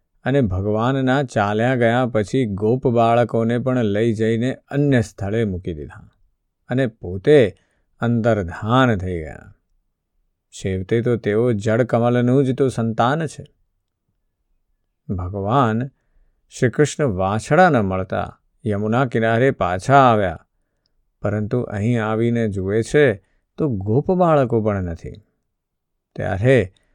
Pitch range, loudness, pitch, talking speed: 100-130 Hz, -19 LUFS, 115 Hz, 105 wpm